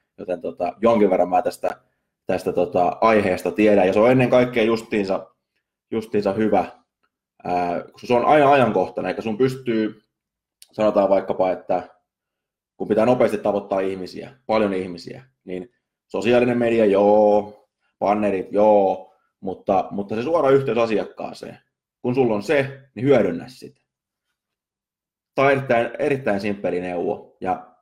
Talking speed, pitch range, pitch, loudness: 135 wpm, 100-120 Hz, 110 Hz, -20 LUFS